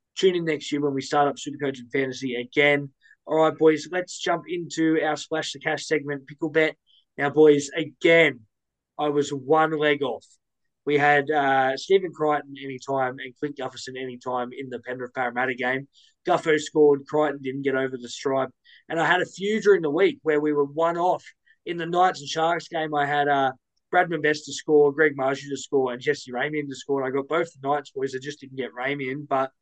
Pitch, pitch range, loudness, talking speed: 145 Hz, 135-160 Hz, -24 LUFS, 210 wpm